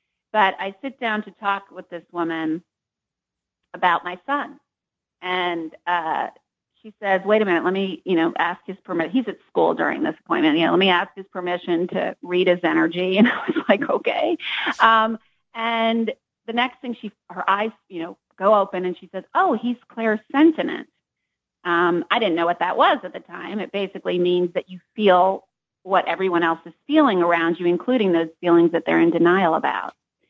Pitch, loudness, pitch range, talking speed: 185 Hz, -21 LUFS, 175-220 Hz, 190 wpm